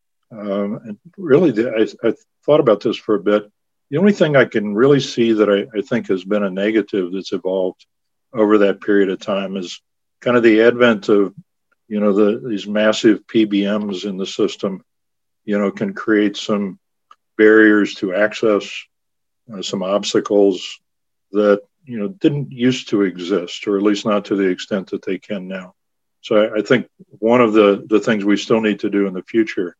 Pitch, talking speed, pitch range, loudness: 105 Hz, 195 wpm, 100-115 Hz, -17 LUFS